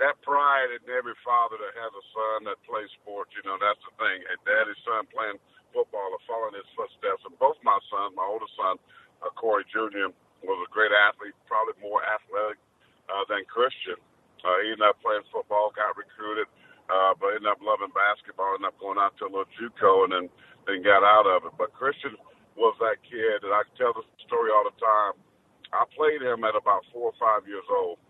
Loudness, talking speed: -26 LUFS, 210 wpm